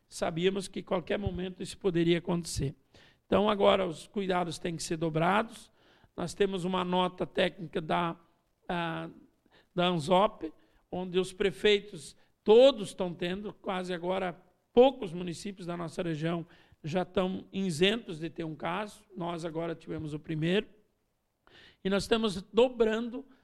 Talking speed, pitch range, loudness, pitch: 140 wpm, 170-200 Hz, -30 LUFS, 185 Hz